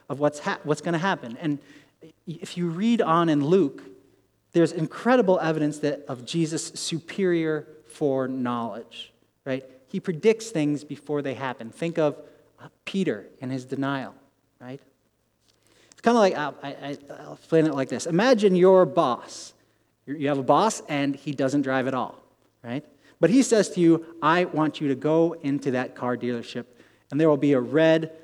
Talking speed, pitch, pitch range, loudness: 170 wpm, 150 Hz, 135-165 Hz, -24 LUFS